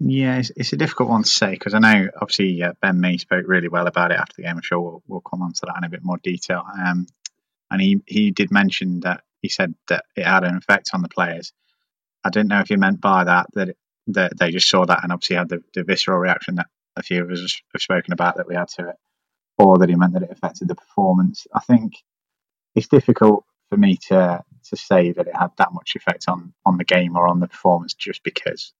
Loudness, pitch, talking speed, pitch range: -19 LUFS, 95 Hz, 255 wpm, 90-125 Hz